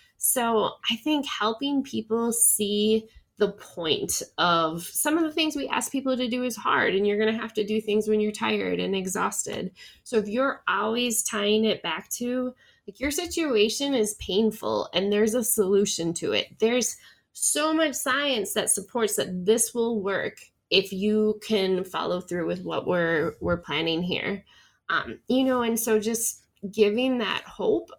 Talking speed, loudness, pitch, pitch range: 175 wpm, -25 LUFS, 220 Hz, 205-250 Hz